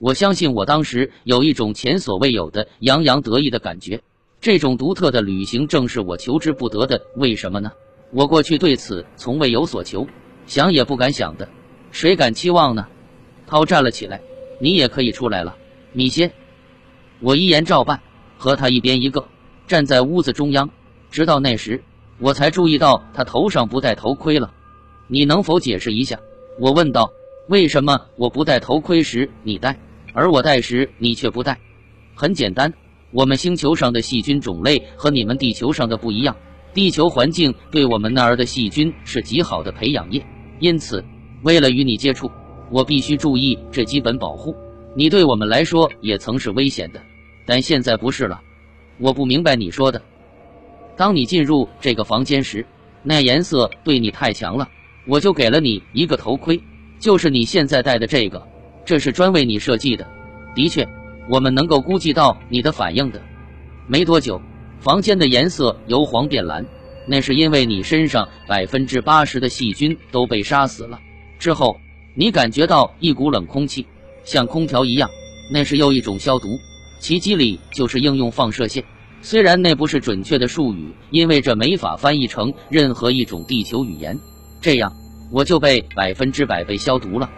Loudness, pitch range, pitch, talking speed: -17 LUFS, 115-150 Hz, 130 Hz, 265 characters per minute